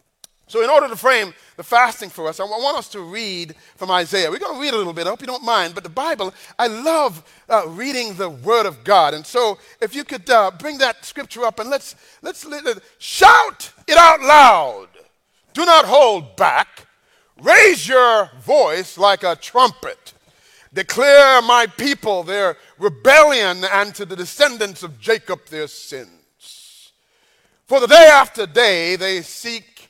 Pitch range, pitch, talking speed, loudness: 190-285 Hz, 235 Hz, 170 wpm, -14 LUFS